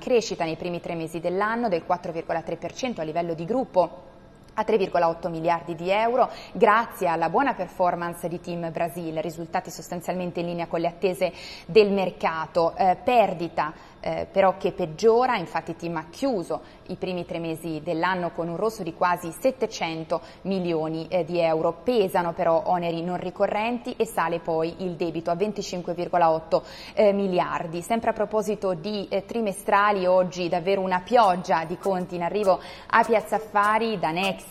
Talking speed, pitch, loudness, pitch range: 160 wpm, 180 Hz, -25 LUFS, 170-200 Hz